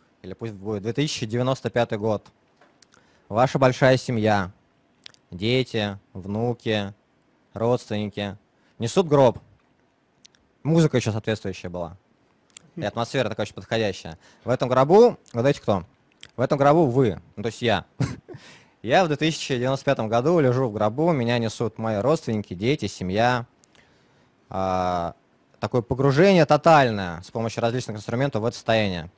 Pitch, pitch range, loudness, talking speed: 115 Hz, 105-135 Hz, -23 LUFS, 120 wpm